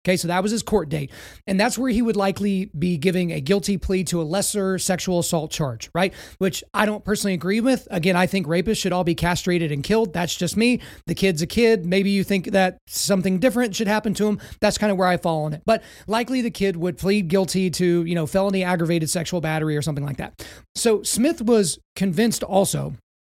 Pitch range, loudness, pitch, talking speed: 175-210 Hz, -22 LUFS, 190 Hz, 230 wpm